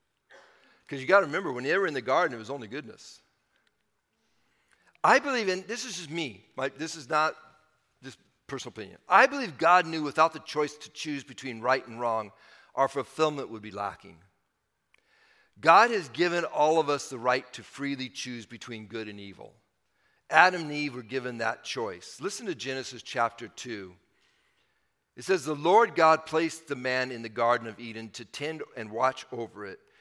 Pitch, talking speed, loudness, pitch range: 135 Hz, 185 wpm, -27 LUFS, 115-160 Hz